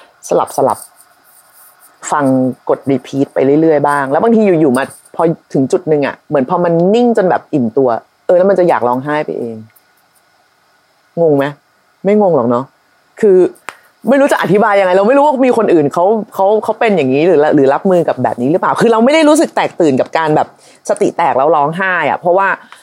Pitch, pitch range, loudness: 175 Hz, 140-215 Hz, -12 LUFS